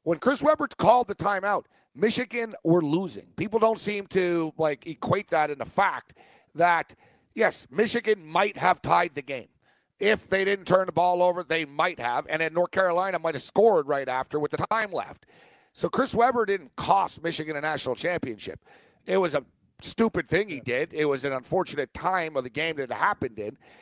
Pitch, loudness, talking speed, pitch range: 175 Hz, -26 LUFS, 195 wpm, 155-205 Hz